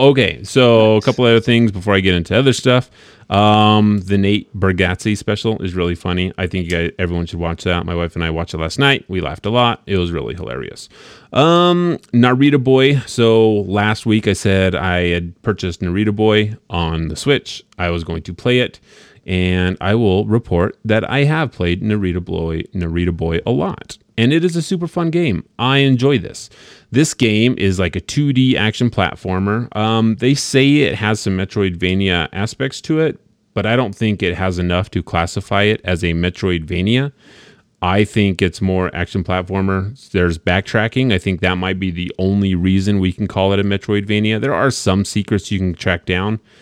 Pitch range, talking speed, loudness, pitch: 90-115 Hz, 195 wpm, -16 LUFS, 100 Hz